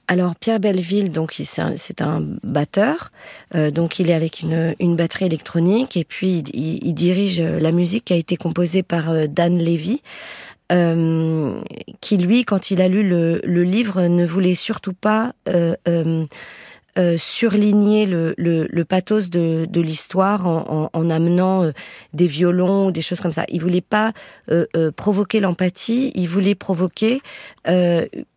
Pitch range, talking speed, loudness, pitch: 165-200 Hz, 170 wpm, -19 LUFS, 175 Hz